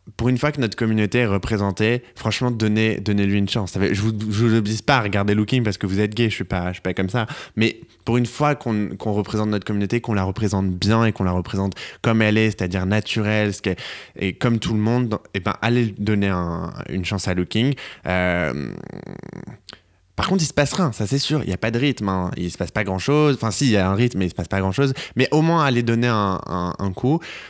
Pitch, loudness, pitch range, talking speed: 105 Hz, -21 LUFS, 95-120 Hz, 260 wpm